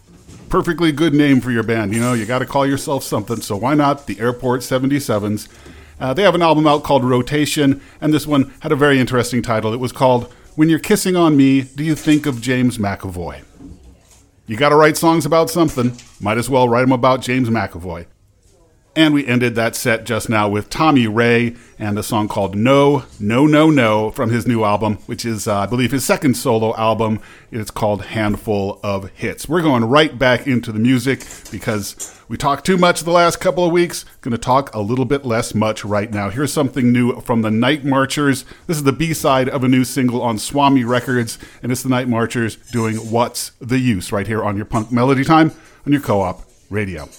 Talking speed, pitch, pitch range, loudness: 210 wpm, 125 Hz, 110-140 Hz, -16 LUFS